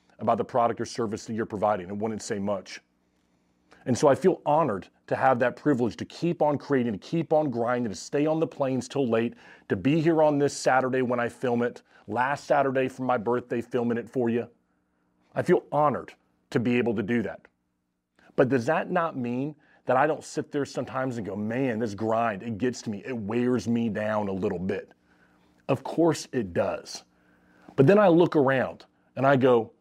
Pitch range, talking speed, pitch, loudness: 105-135 Hz, 205 wpm, 120 Hz, -26 LUFS